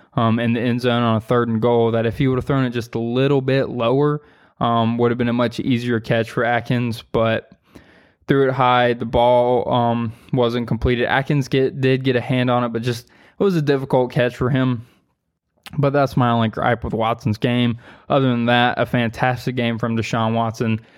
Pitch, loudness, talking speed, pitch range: 120 Hz, -19 LUFS, 215 wpm, 115-130 Hz